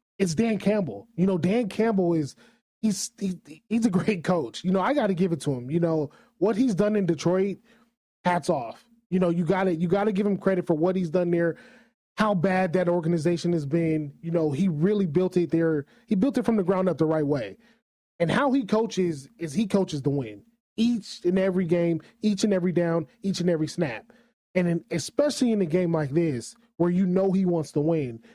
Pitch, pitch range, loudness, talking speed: 185 Hz, 170-210 Hz, -25 LUFS, 220 wpm